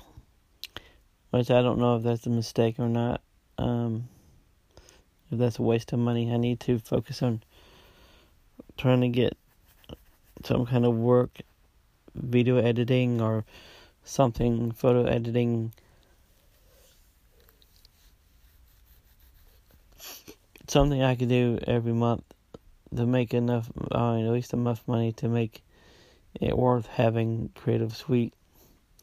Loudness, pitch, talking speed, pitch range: -27 LUFS, 120 Hz, 115 wpm, 115-125 Hz